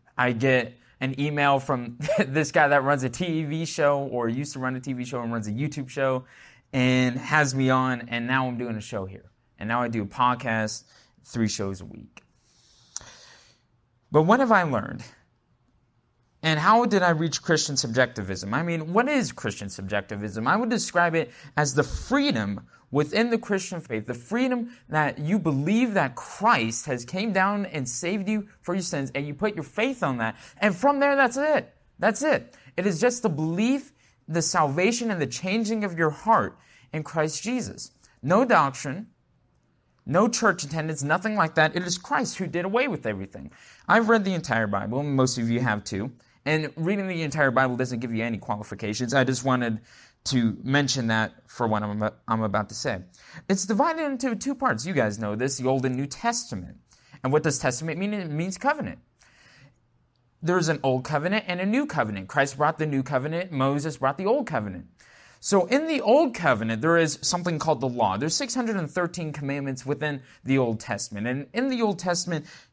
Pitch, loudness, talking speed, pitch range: 145 Hz, -25 LUFS, 190 wpm, 125-185 Hz